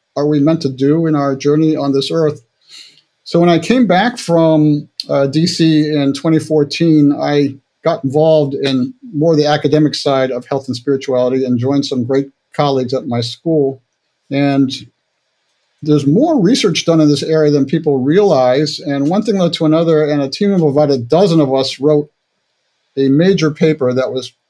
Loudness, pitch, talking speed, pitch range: -13 LUFS, 145 Hz, 180 wpm, 135-160 Hz